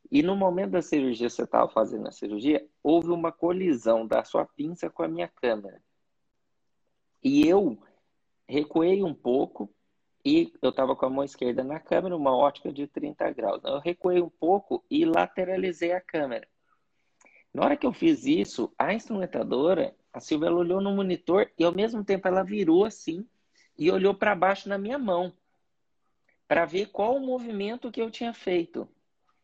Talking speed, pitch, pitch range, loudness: 175 wpm, 185 Hz, 170-225 Hz, -27 LUFS